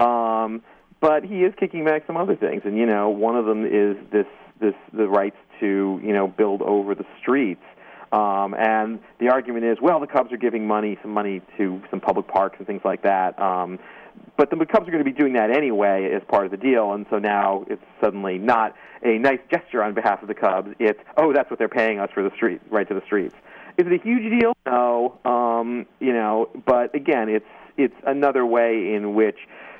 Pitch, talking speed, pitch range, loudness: 115 Hz, 220 wpm, 105-140 Hz, -22 LUFS